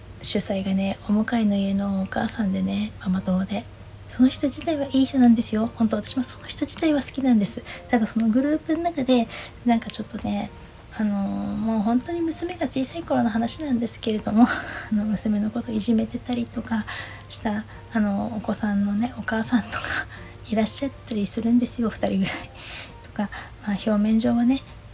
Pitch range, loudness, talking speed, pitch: 205-245 Hz, -24 LUFS, 365 characters per minute, 220 Hz